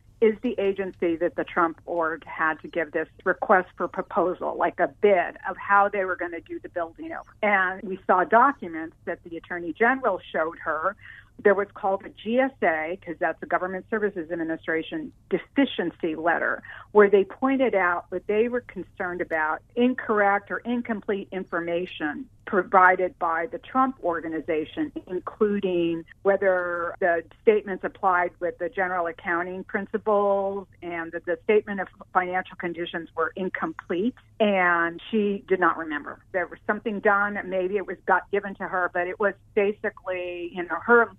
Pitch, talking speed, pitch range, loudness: 185 Hz, 160 wpm, 170-205 Hz, -25 LUFS